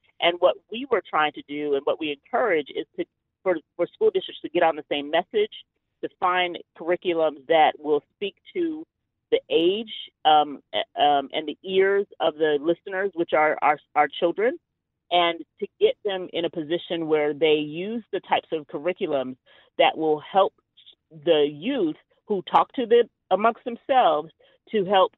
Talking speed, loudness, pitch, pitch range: 170 wpm, -24 LUFS, 180 Hz, 155-245 Hz